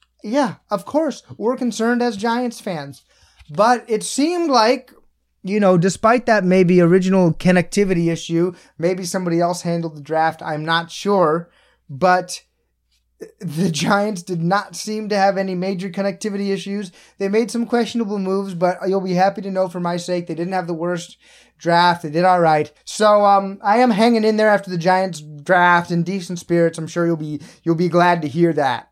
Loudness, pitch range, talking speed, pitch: -18 LUFS, 170-205 Hz, 185 wpm, 185 Hz